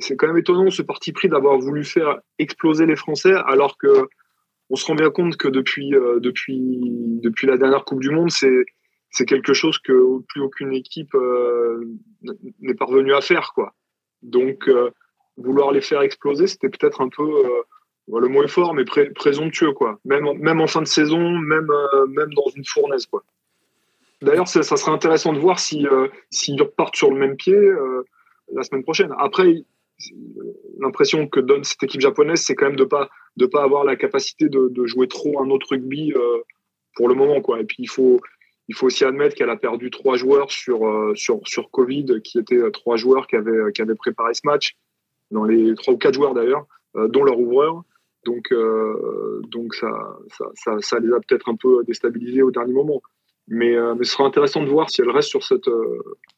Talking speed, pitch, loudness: 205 wpm, 170 Hz, -19 LUFS